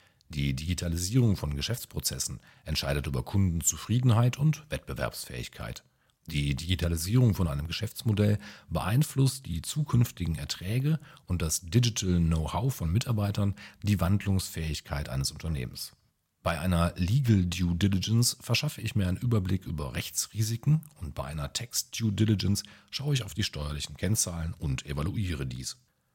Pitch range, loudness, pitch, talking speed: 80-115 Hz, -29 LUFS, 95 Hz, 125 wpm